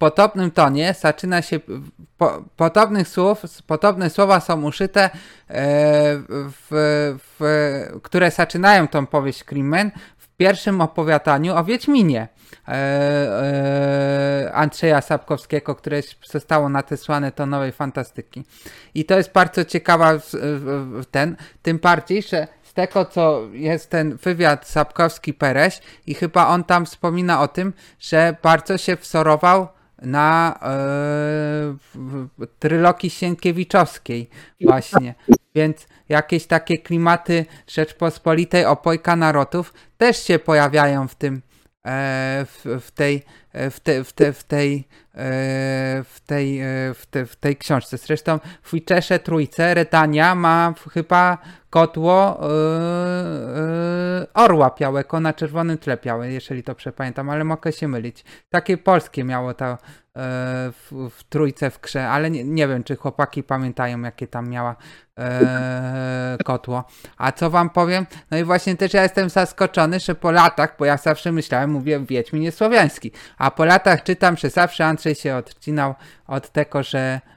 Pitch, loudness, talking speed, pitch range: 155 Hz, -19 LUFS, 125 wpm, 140-175 Hz